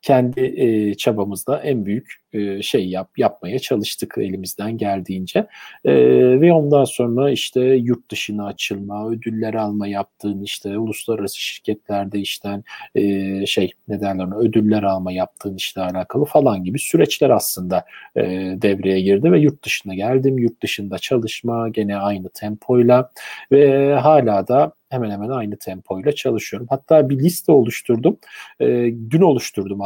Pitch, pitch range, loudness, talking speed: 105 Hz, 100-125 Hz, -18 LUFS, 135 wpm